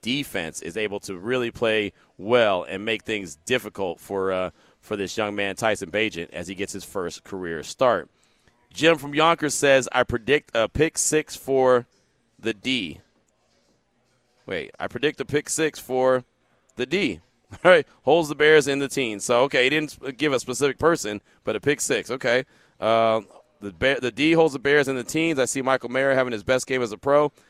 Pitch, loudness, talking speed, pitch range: 125 Hz, -23 LUFS, 195 wpm, 105-140 Hz